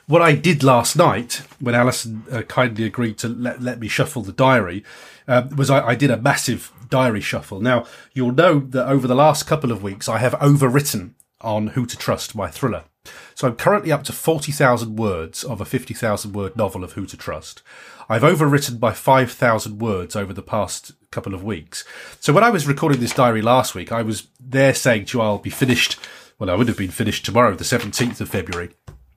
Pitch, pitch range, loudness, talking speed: 120 Hz, 110-135 Hz, -19 LUFS, 210 wpm